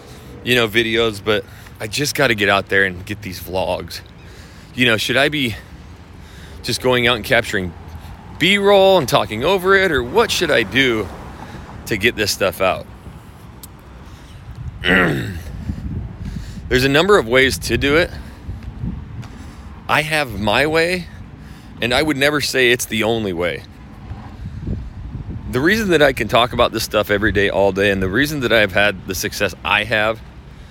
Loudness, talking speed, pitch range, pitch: -16 LUFS, 165 wpm, 95-125 Hz, 105 Hz